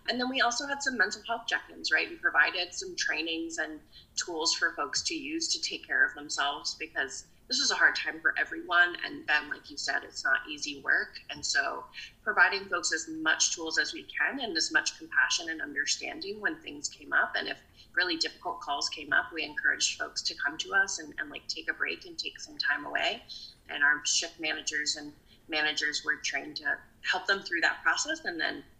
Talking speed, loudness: 215 wpm, -29 LUFS